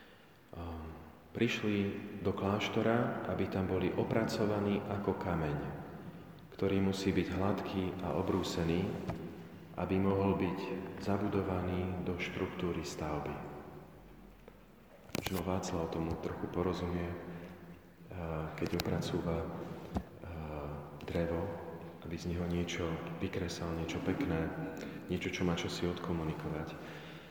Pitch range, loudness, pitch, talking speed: 85-95 Hz, -37 LUFS, 90 Hz, 95 wpm